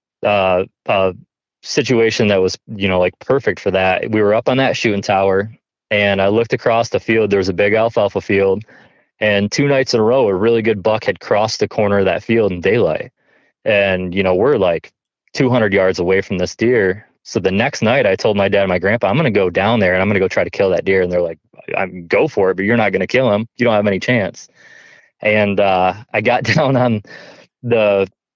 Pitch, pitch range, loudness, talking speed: 105 Hz, 95-115 Hz, -15 LUFS, 235 wpm